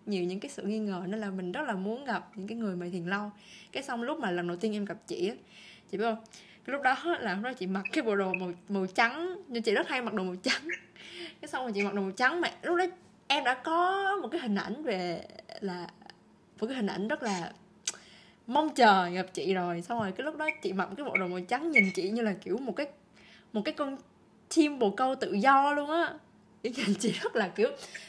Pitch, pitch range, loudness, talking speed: 215 Hz, 195-275 Hz, -31 LUFS, 255 wpm